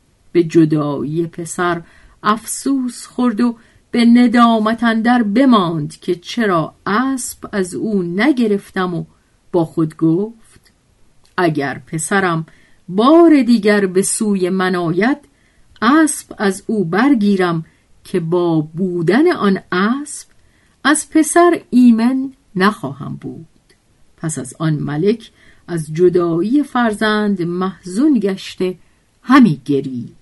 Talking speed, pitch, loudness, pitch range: 105 wpm, 195 Hz, -15 LUFS, 170-240 Hz